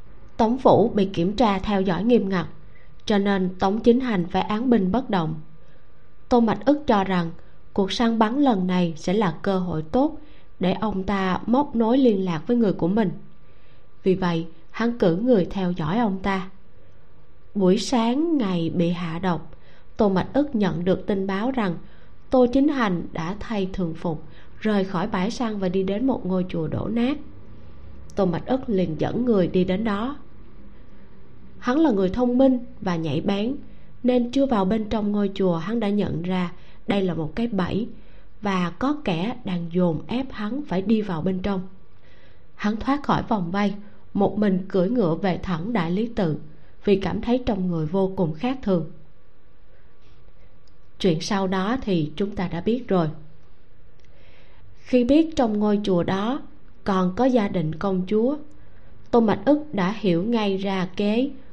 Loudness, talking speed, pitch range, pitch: -23 LUFS, 180 wpm, 180-235 Hz, 195 Hz